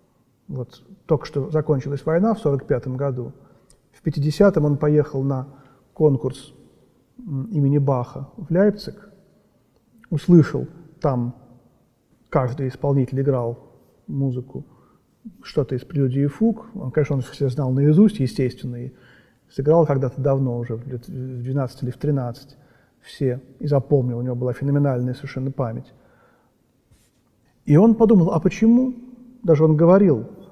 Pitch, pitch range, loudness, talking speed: 140 Hz, 130-160 Hz, -21 LUFS, 125 wpm